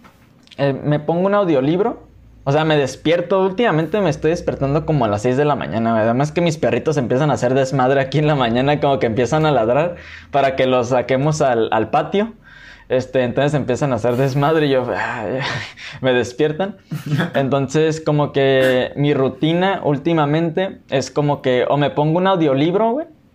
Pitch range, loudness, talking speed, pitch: 130-160 Hz, -17 LUFS, 185 wpm, 145 Hz